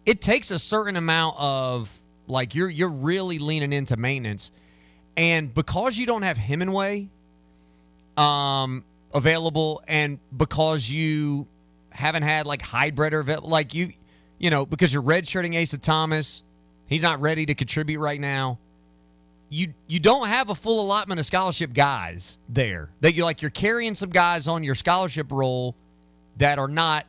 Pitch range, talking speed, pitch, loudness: 125-170 Hz, 155 wpm, 150 Hz, -23 LUFS